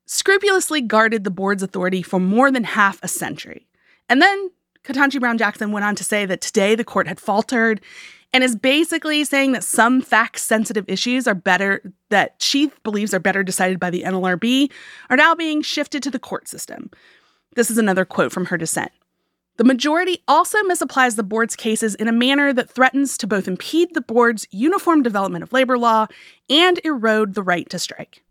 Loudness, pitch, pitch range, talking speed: -18 LUFS, 230 Hz, 200-280 Hz, 180 wpm